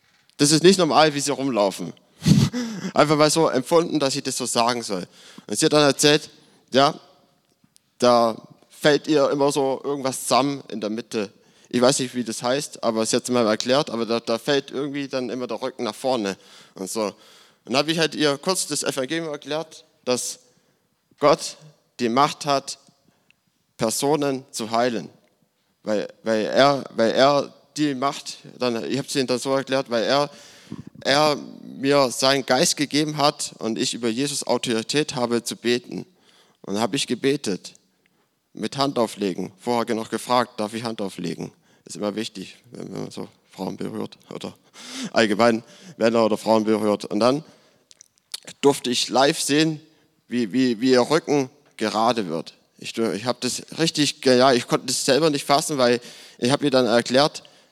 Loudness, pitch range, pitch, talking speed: -22 LUFS, 120-150 Hz, 135 Hz, 175 wpm